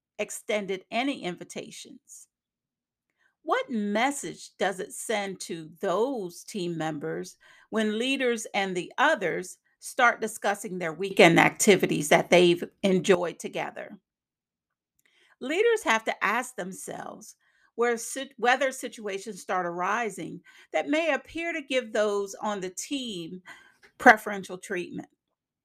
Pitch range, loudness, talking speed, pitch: 185-250 Hz, -26 LUFS, 110 wpm, 215 Hz